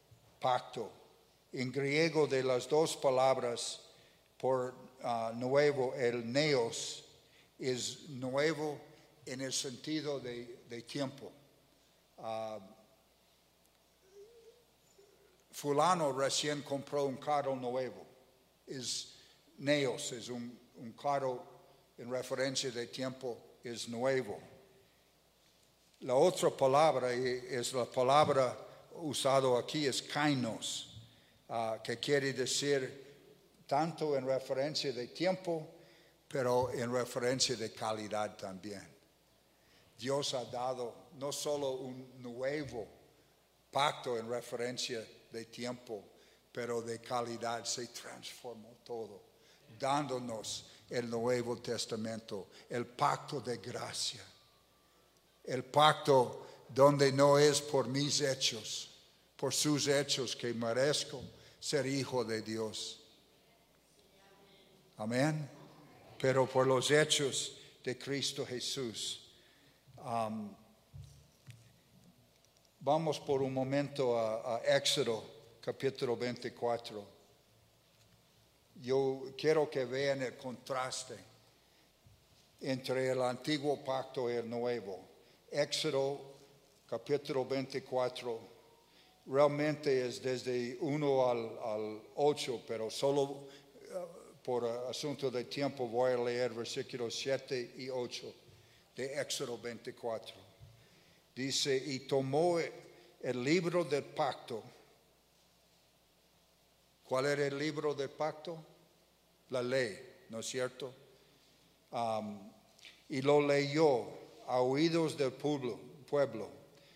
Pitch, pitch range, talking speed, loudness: 130 Hz, 120-145 Hz, 100 wpm, -35 LUFS